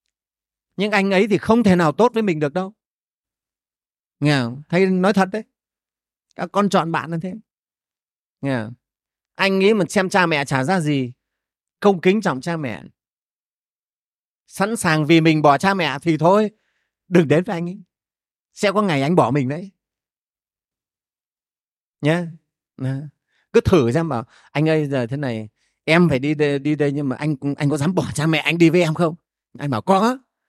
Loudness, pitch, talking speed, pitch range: -19 LUFS, 165 Hz, 185 wpm, 145-190 Hz